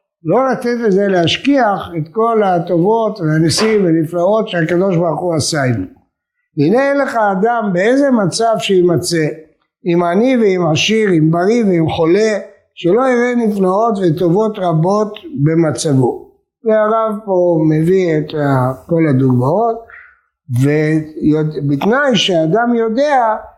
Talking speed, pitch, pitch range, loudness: 110 wpm, 185 Hz, 160-225 Hz, -14 LUFS